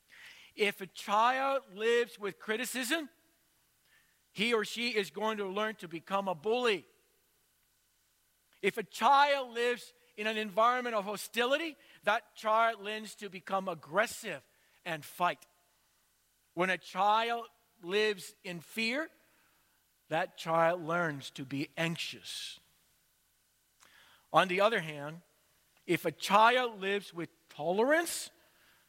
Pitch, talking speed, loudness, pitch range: 210 Hz, 115 wpm, -32 LUFS, 180-235 Hz